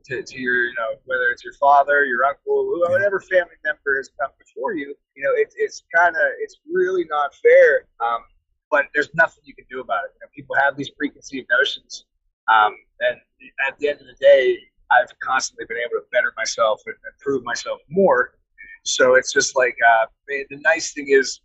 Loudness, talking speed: -19 LUFS, 200 wpm